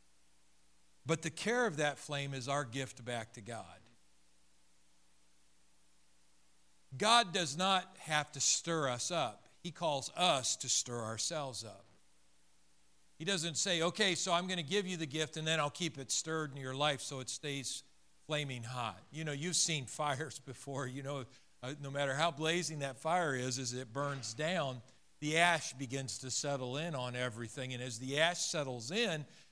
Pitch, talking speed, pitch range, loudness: 135 Hz, 175 wpm, 115-160 Hz, -36 LUFS